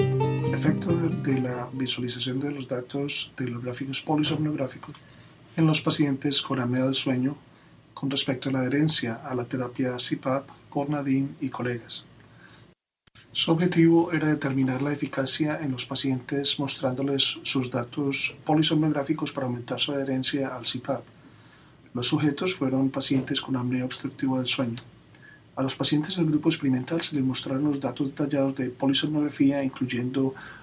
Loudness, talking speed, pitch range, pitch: -25 LUFS, 145 wpm, 130-145 Hz, 135 Hz